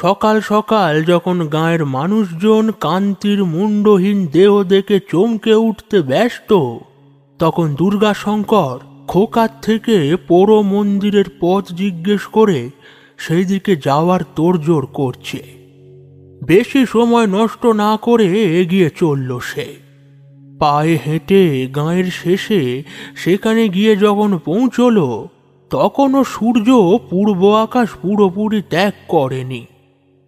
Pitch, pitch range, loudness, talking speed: 190 Hz, 150-210 Hz, -14 LUFS, 95 wpm